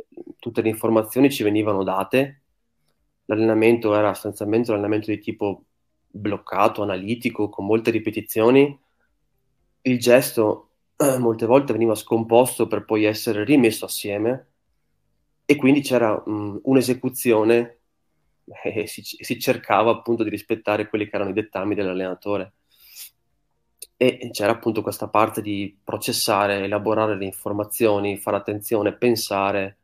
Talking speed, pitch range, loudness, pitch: 120 wpm, 105-120 Hz, -21 LUFS, 110 Hz